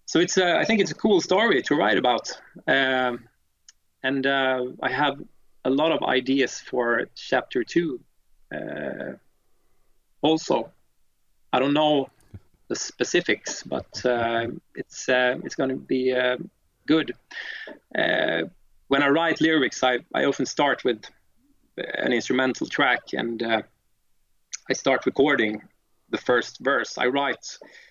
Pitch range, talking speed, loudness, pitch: 115-155 Hz, 140 wpm, -24 LUFS, 130 Hz